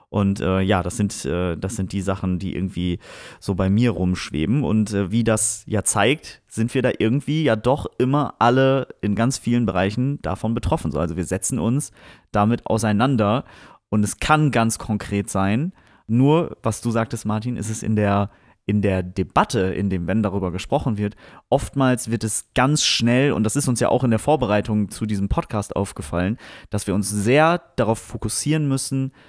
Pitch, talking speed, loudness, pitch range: 110 Hz, 190 wpm, -21 LUFS, 100-125 Hz